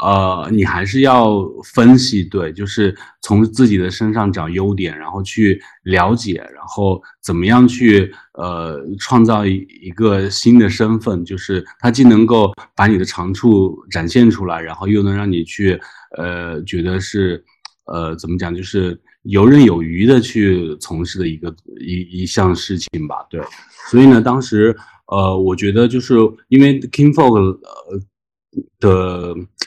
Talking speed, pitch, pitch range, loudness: 225 characters per minute, 100 Hz, 90-115 Hz, -14 LUFS